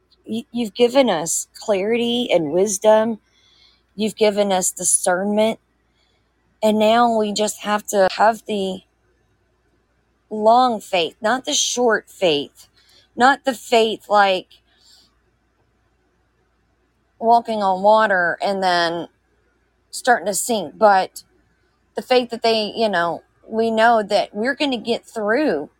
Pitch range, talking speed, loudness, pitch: 200-235 Hz, 120 wpm, -18 LUFS, 215 Hz